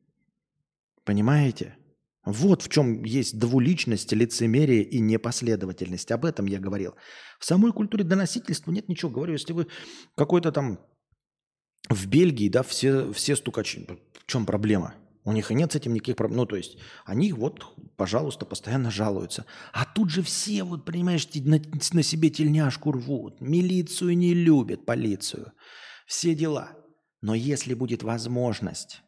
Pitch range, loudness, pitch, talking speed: 115-165 Hz, -25 LUFS, 140 Hz, 145 wpm